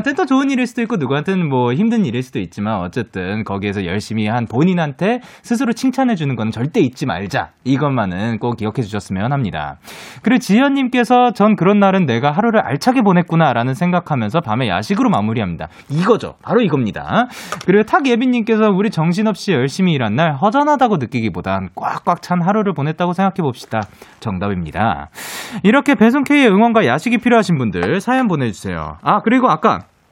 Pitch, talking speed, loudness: 175 Hz, 415 characters per minute, -16 LUFS